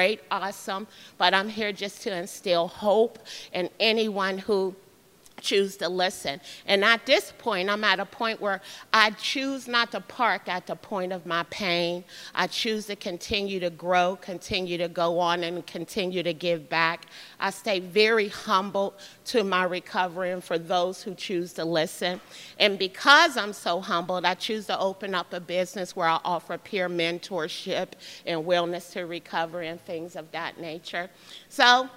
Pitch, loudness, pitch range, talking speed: 185 Hz, -26 LUFS, 175-205 Hz, 170 wpm